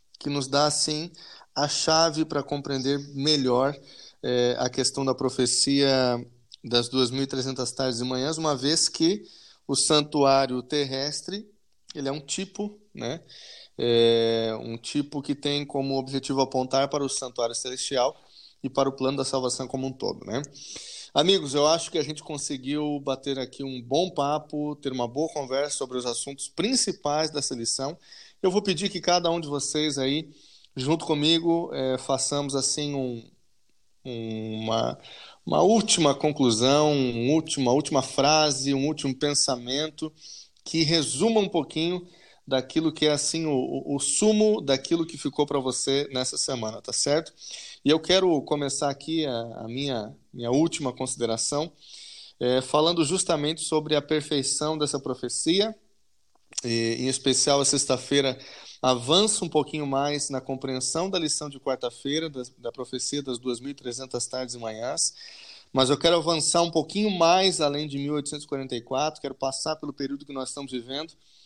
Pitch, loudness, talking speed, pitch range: 140 Hz, -25 LUFS, 150 wpm, 130-155 Hz